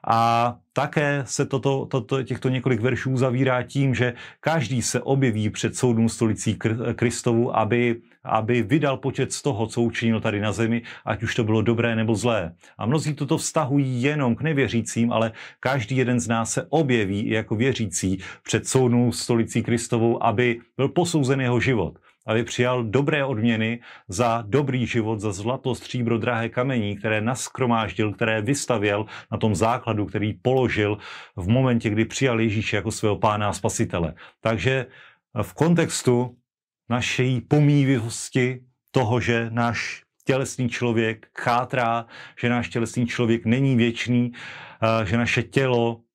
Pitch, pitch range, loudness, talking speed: 120 Hz, 115-130 Hz, -23 LUFS, 150 wpm